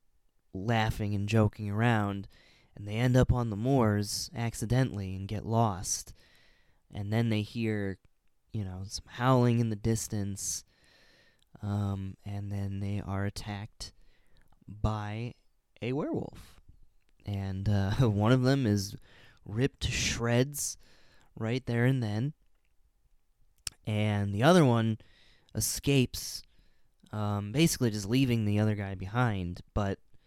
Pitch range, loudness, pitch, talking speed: 100-120 Hz, -30 LUFS, 105 Hz, 125 wpm